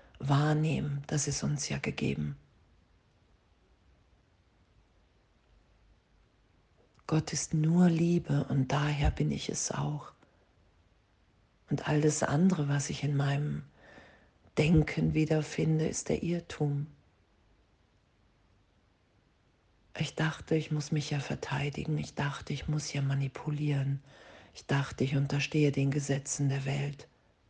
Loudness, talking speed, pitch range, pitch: -31 LUFS, 105 wpm, 95-150 Hz, 140 Hz